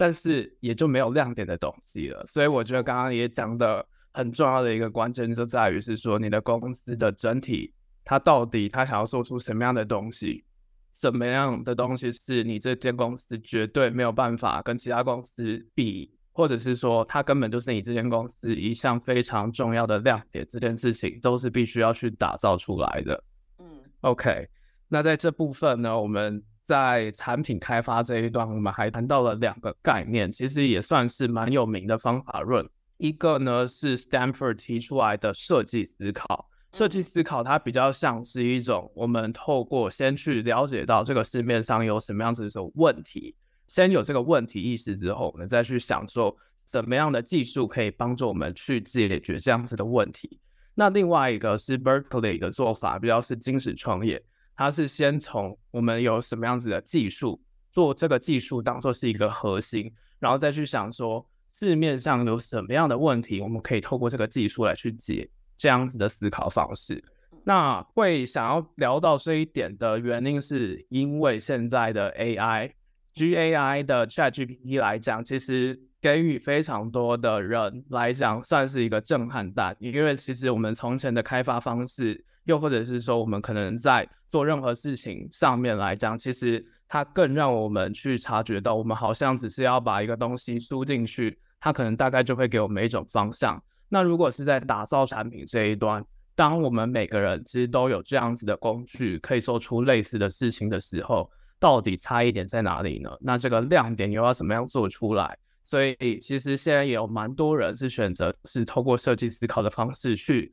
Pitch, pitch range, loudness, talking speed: 120 Hz, 110-130 Hz, -26 LUFS, 295 characters per minute